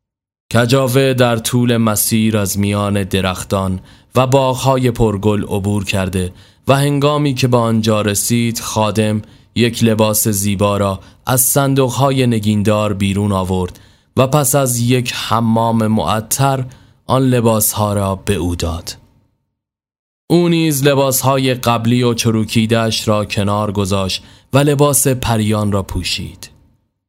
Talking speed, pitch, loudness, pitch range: 120 wpm, 110 Hz, -15 LUFS, 100-130 Hz